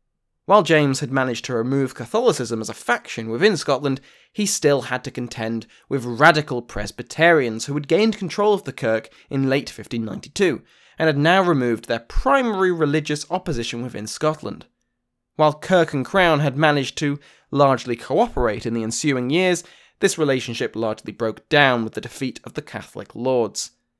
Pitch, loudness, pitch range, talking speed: 135 Hz, -21 LUFS, 120-160 Hz, 165 wpm